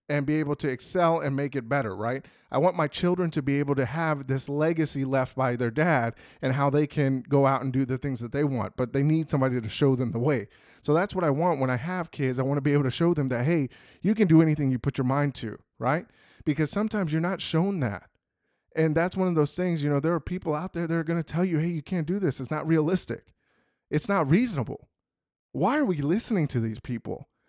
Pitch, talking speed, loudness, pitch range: 150 Hz, 255 wpm, -26 LUFS, 135-170 Hz